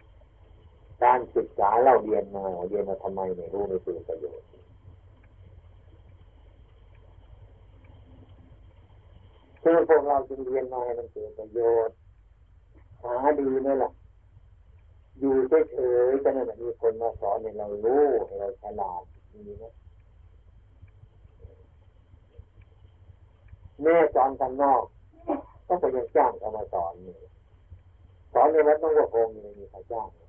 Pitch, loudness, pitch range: 95 Hz, -25 LUFS, 90-125 Hz